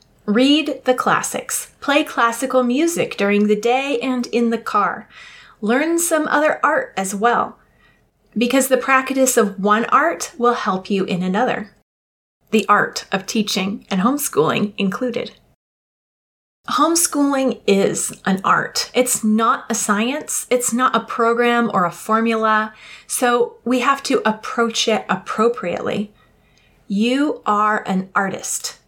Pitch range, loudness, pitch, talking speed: 210-255 Hz, -18 LUFS, 235 Hz, 130 wpm